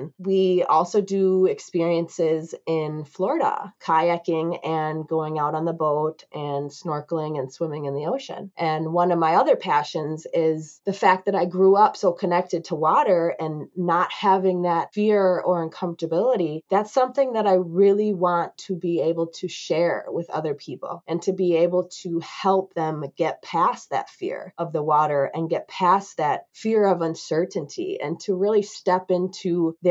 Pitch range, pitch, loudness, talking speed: 160-190 Hz, 170 Hz, -23 LUFS, 170 wpm